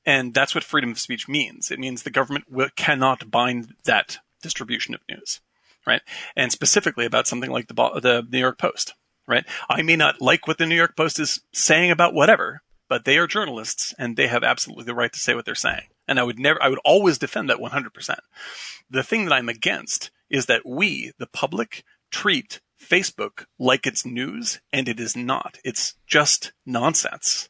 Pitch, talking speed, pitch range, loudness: 135 Hz, 195 wpm, 125-155 Hz, -21 LUFS